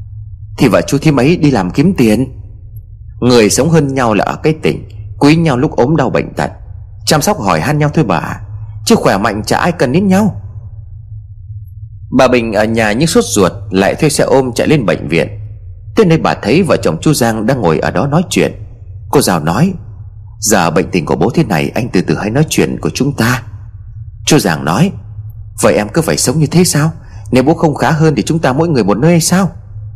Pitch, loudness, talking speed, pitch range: 110 Hz, -12 LUFS, 225 wpm, 105-150 Hz